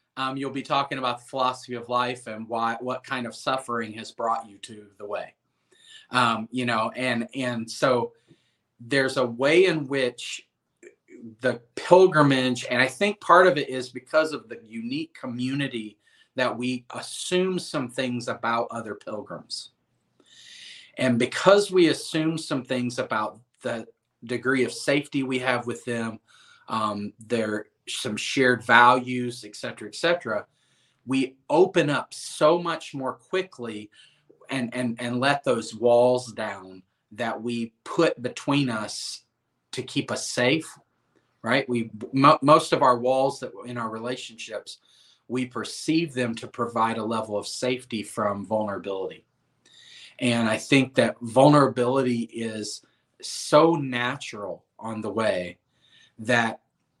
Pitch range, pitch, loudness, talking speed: 115-135 Hz, 125 Hz, -25 LUFS, 140 wpm